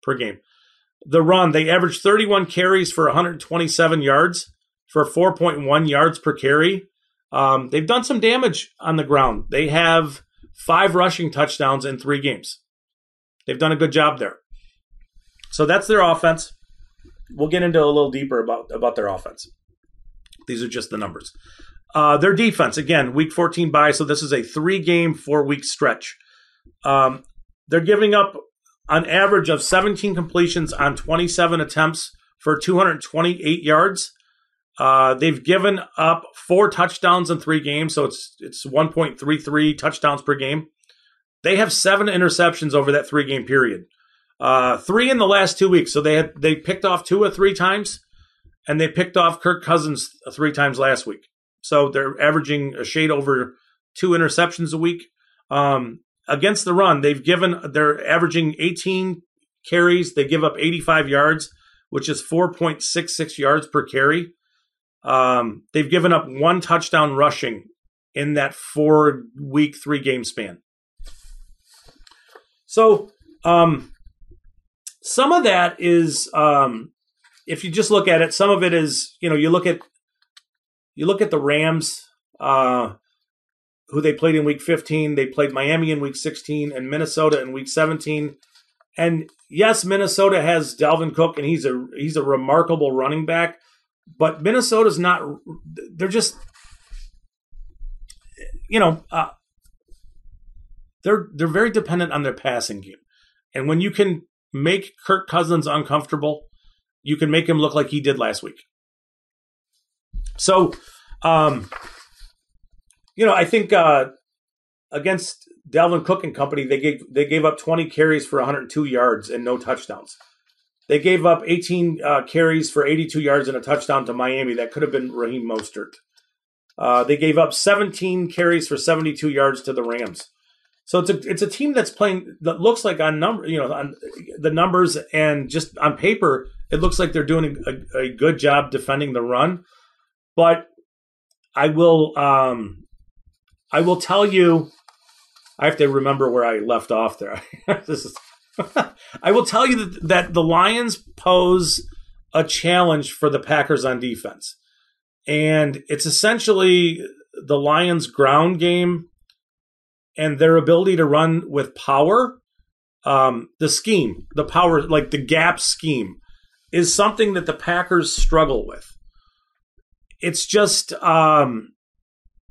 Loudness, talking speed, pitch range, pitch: -18 LUFS, 155 wpm, 145-175 Hz, 160 Hz